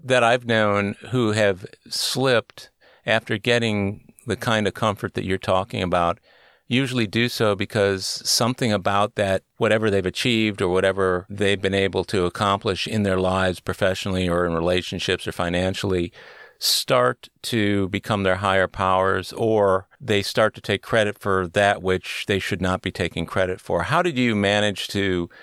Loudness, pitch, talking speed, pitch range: -22 LUFS, 100 Hz, 165 wpm, 95-110 Hz